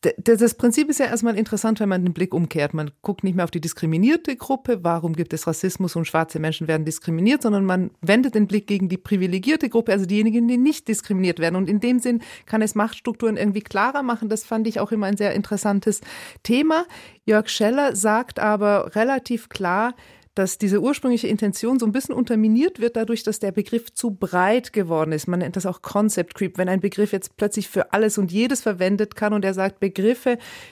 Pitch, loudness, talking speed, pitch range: 210 Hz, -21 LUFS, 205 wpm, 190-235 Hz